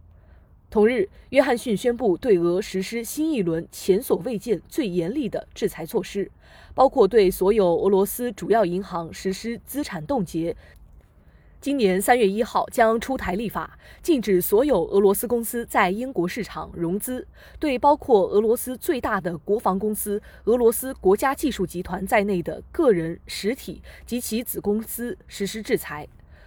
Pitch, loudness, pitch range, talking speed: 205 Hz, -23 LUFS, 185-245 Hz, 245 characters per minute